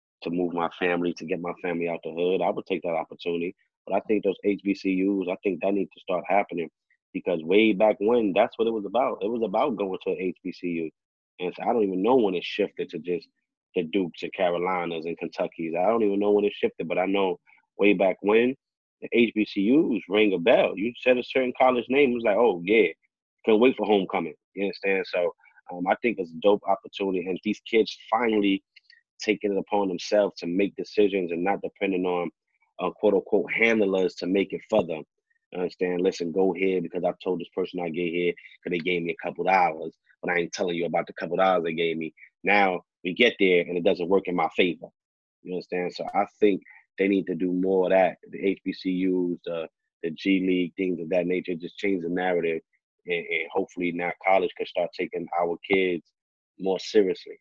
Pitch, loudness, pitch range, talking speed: 95 Hz, -25 LUFS, 90-105 Hz, 215 wpm